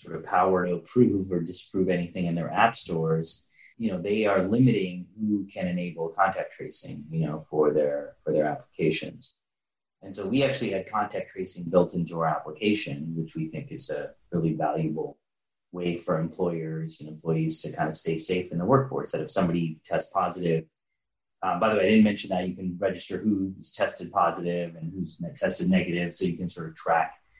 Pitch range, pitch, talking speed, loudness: 80-95 Hz, 85 Hz, 195 wpm, -27 LUFS